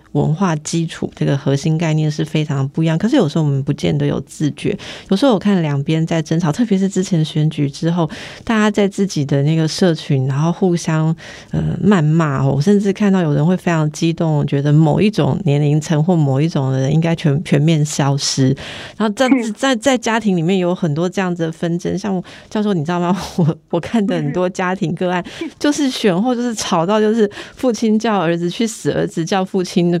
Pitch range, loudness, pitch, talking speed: 155-195 Hz, -17 LUFS, 170 Hz, 310 characters per minute